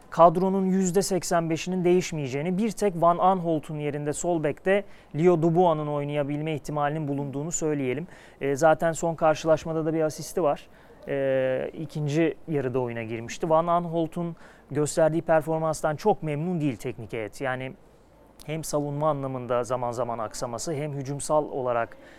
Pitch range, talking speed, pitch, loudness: 140-170 Hz, 135 wpm, 155 Hz, -26 LUFS